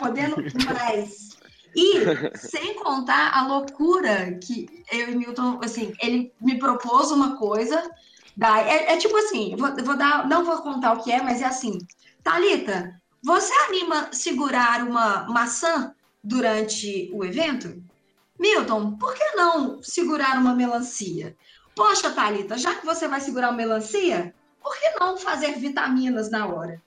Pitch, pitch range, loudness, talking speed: 255 Hz, 225-320 Hz, -23 LUFS, 145 wpm